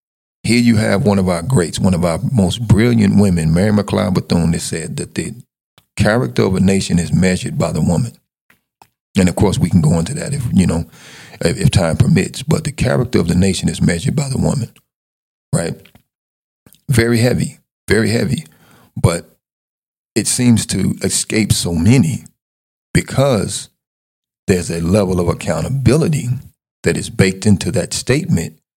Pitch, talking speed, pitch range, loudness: 100 Hz, 165 wpm, 90-115 Hz, -16 LUFS